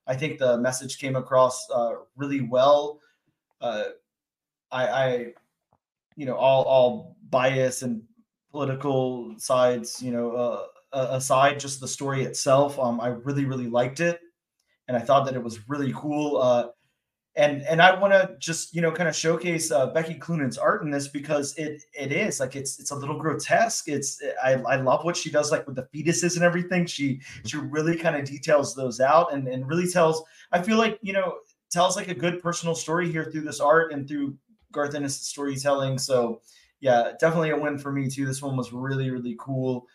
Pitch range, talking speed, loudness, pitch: 130-165 Hz, 195 wpm, -25 LUFS, 140 Hz